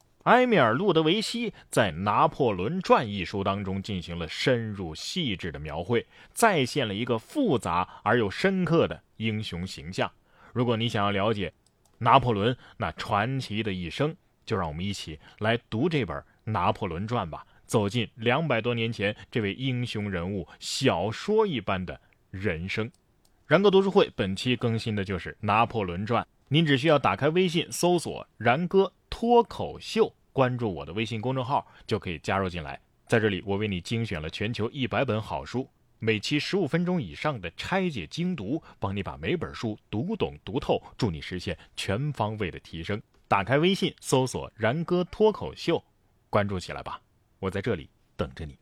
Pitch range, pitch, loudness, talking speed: 100-140 Hz, 110 Hz, -27 LUFS, 260 characters per minute